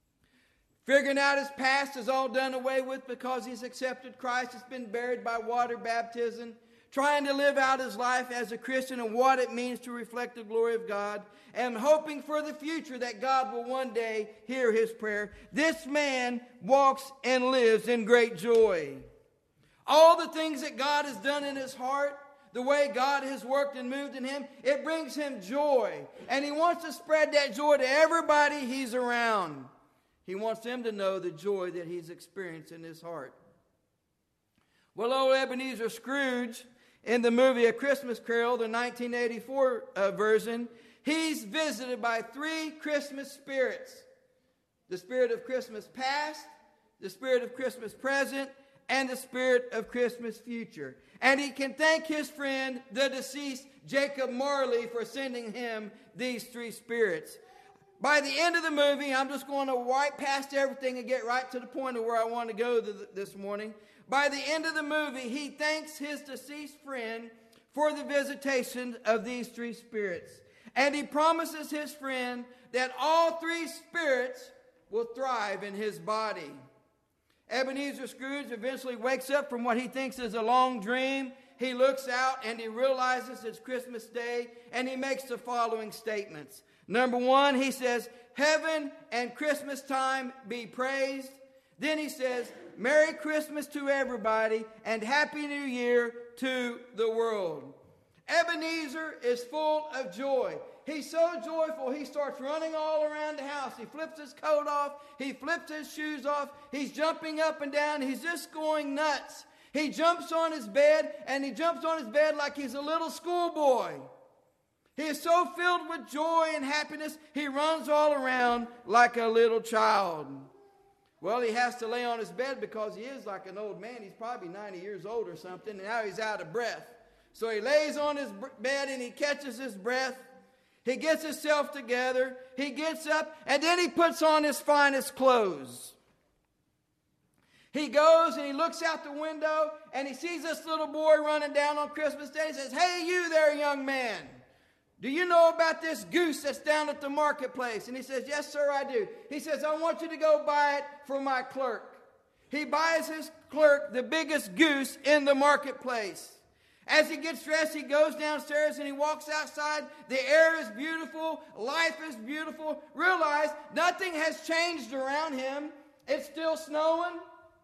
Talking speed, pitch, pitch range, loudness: 175 wpm, 270 Hz, 245-300 Hz, -30 LUFS